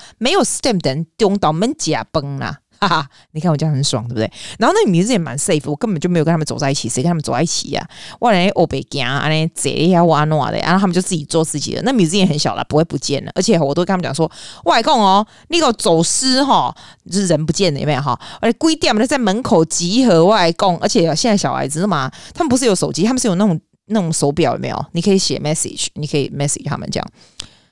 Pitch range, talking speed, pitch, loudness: 150-200 Hz, 415 characters per minute, 170 Hz, -16 LUFS